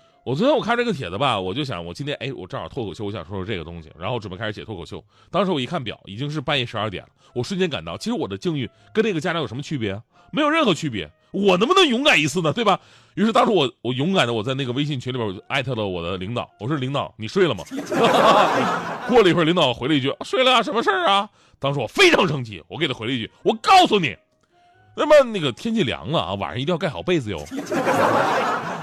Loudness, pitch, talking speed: -21 LUFS, 140 Hz, 390 characters per minute